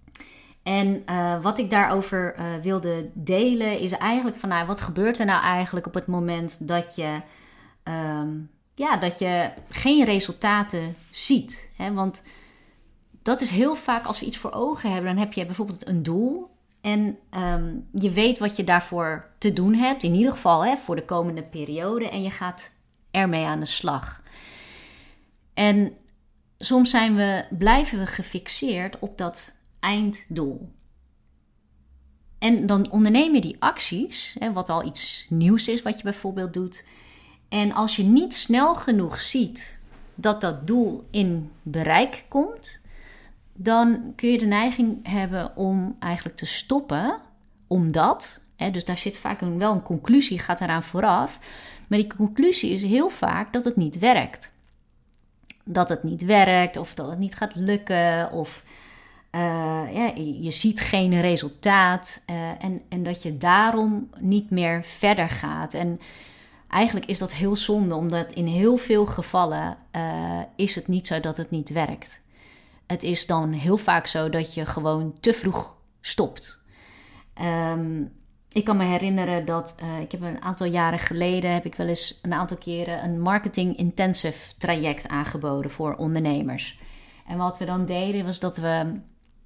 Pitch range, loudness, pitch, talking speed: 165-210 Hz, -24 LUFS, 185 Hz, 160 wpm